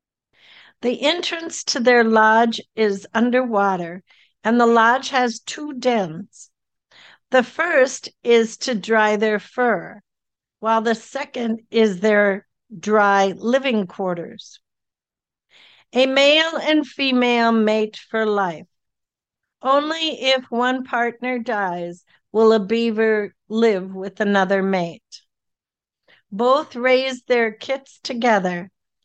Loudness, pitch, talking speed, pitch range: -19 LUFS, 230 Hz, 105 wpm, 210-255 Hz